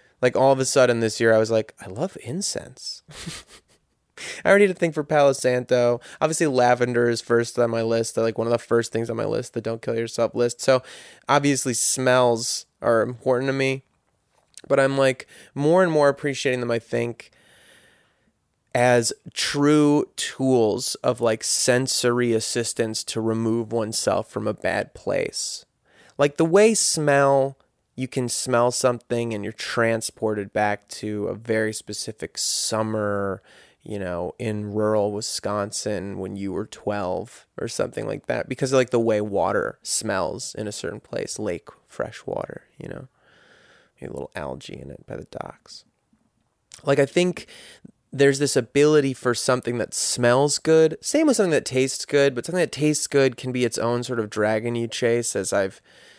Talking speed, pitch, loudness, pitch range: 175 wpm, 120 Hz, -22 LUFS, 115-135 Hz